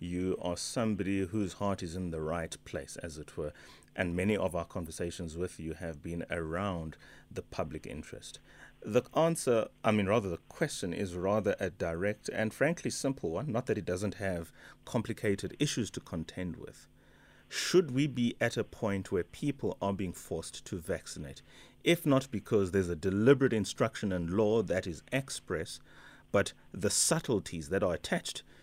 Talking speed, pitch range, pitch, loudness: 175 wpm, 85-115 Hz, 100 Hz, -33 LUFS